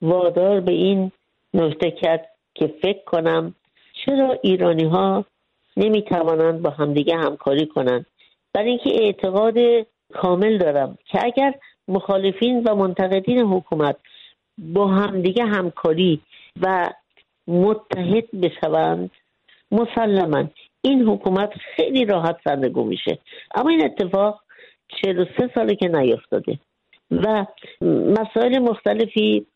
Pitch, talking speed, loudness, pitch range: 195 Hz, 105 wpm, -20 LUFS, 170-220 Hz